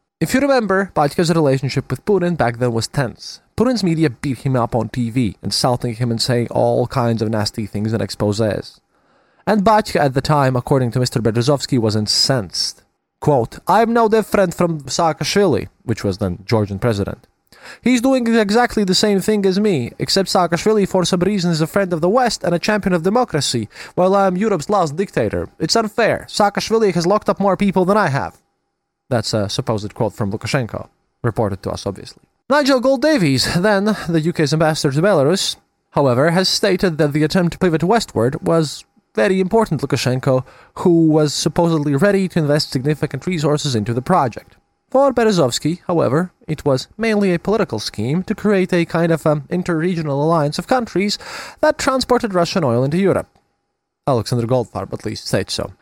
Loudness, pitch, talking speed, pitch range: -17 LUFS, 165 Hz, 180 wpm, 125-200 Hz